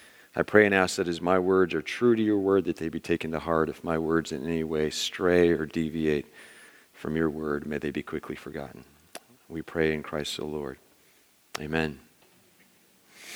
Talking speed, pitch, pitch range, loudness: 195 wpm, 80 Hz, 75-90 Hz, -27 LUFS